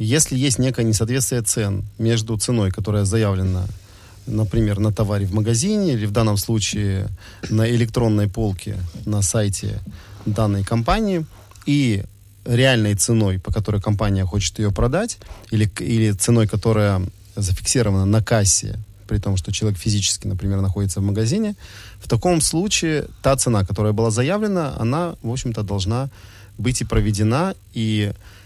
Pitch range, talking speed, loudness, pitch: 100-115 Hz, 140 wpm, -20 LUFS, 110 Hz